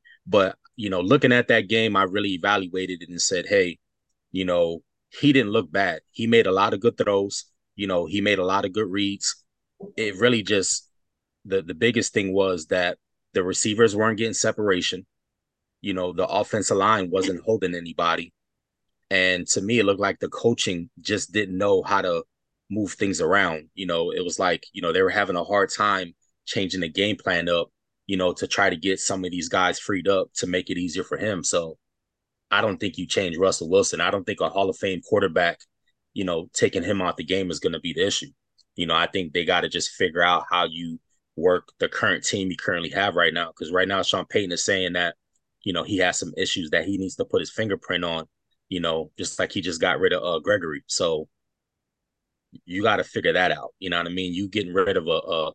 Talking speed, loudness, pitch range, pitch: 225 wpm, -23 LUFS, 90-110 Hz, 95 Hz